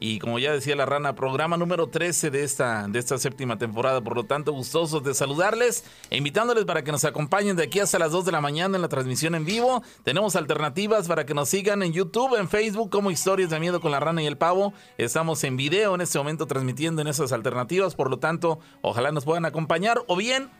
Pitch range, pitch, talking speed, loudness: 140-190 Hz, 160 Hz, 230 wpm, -24 LUFS